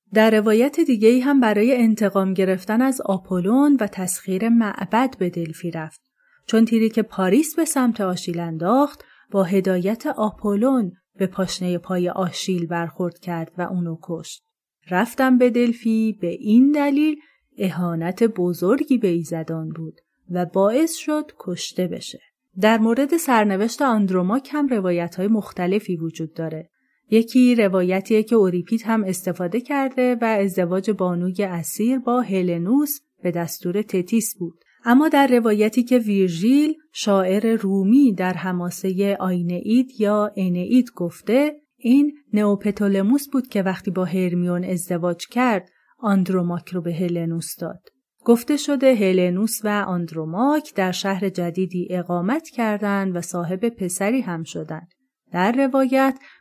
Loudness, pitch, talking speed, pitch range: -20 LUFS, 200 Hz, 130 wpm, 180-245 Hz